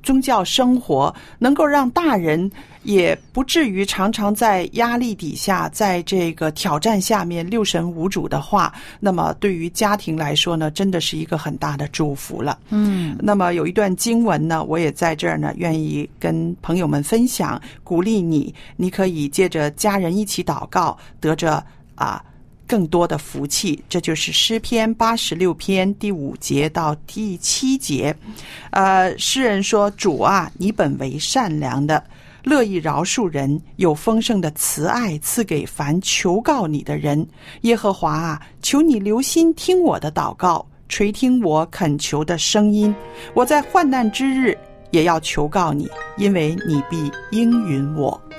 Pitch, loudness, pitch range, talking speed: 180 Hz, -19 LUFS, 155-215 Hz, 230 characters per minute